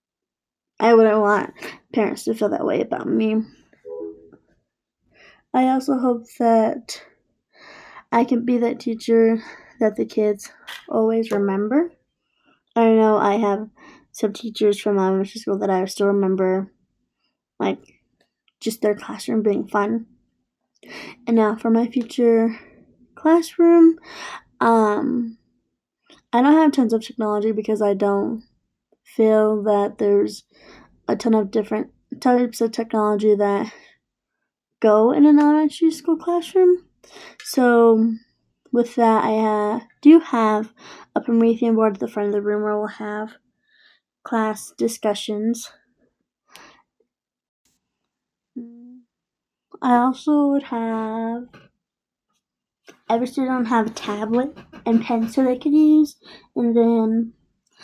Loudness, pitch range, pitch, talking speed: -19 LUFS, 215-250 Hz, 230 Hz, 120 wpm